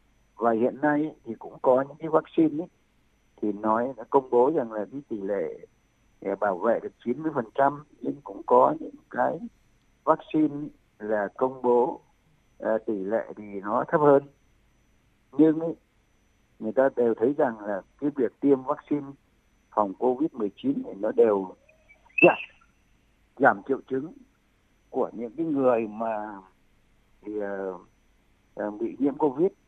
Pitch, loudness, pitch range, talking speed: 130 Hz, -26 LUFS, 110-155 Hz, 145 wpm